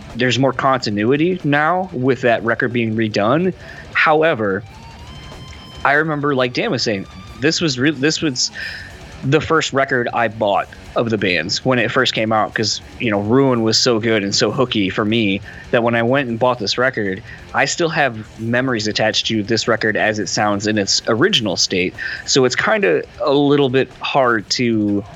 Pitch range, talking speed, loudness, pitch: 110-135 Hz, 185 wpm, -17 LUFS, 120 Hz